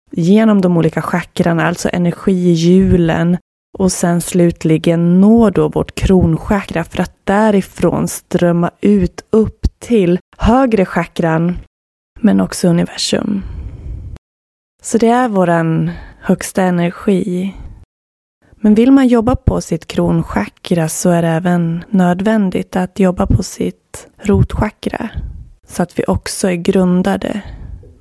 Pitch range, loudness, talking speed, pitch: 165-195 Hz, -14 LUFS, 115 wpm, 175 Hz